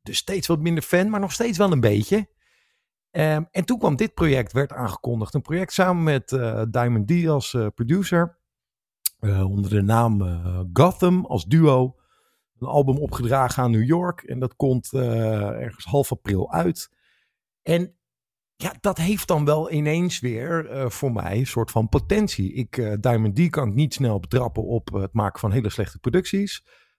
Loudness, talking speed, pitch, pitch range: -22 LUFS, 185 wpm, 130 Hz, 110-170 Hz